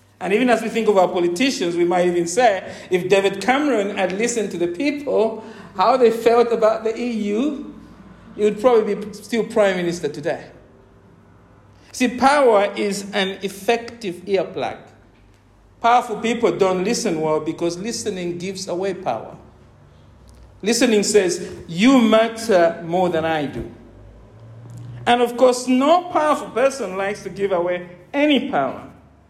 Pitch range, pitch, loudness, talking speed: 175-235 Hz, 200 Hz, -19 LUFS, 145 wpm